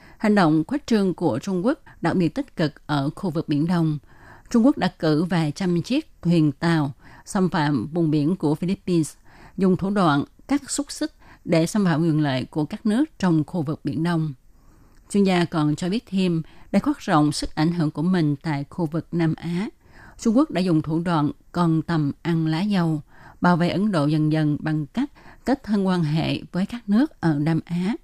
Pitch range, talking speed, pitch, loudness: 155-195 Hz, 210 wpm, 170 Hz, -23 LUFS